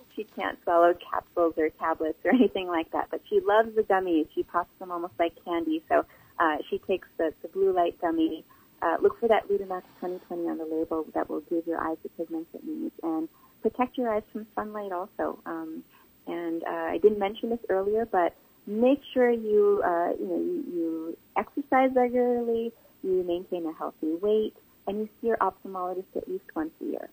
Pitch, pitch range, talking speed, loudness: 195 Hz, 170-245 Hz, 195 wpm, -28 LUFS